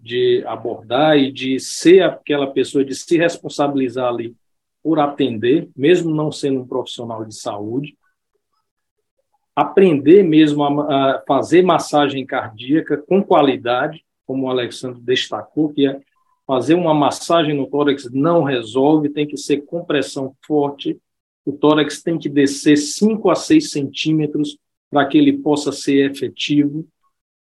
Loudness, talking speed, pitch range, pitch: -17 LUFS, 135 wpm, 135-170 Hz, 145 Hz